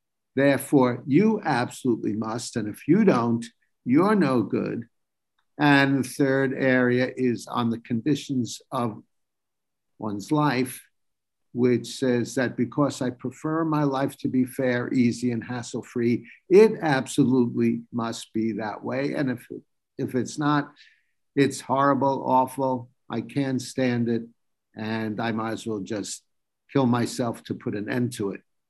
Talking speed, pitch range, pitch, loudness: 145 wpm, 115-135 Hz, 125 Hz, -25 LUFS